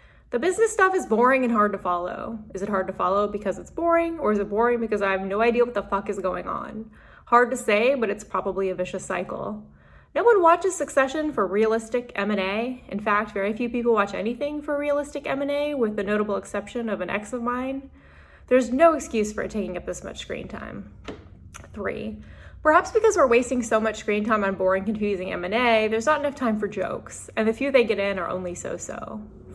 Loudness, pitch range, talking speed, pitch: -24 LUFS, 200-265 Hz, 215 wpm, 220 Hz